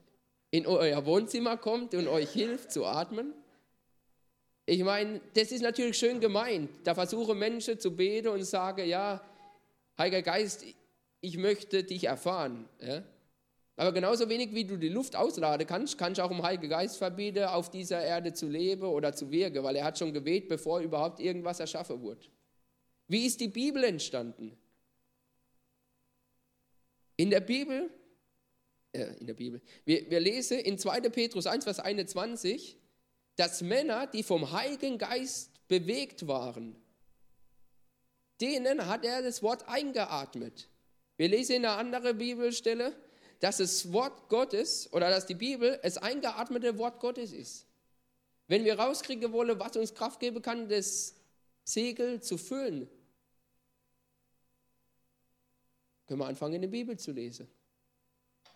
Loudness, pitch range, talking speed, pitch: -32 LUFS, 170-235 Hz, 140 wpm, 195 Hz